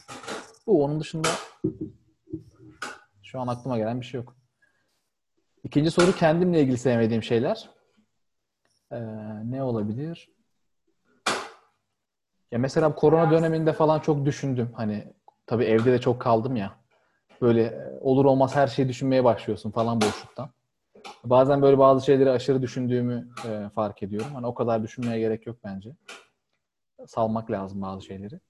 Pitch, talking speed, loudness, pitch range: 125 Hz, 130 wpm, -24 LUFS, 115-140 Hz